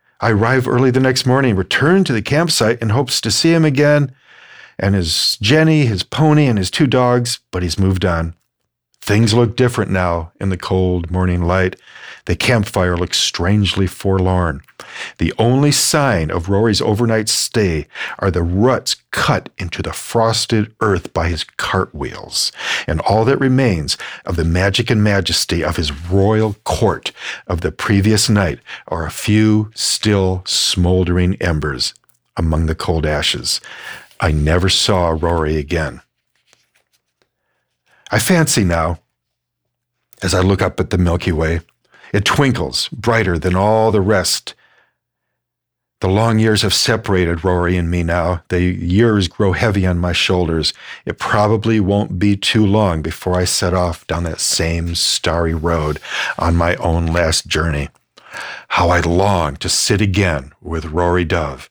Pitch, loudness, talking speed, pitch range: 95 Hz, -16 LUFS, 155 wpm, 85-110 Hz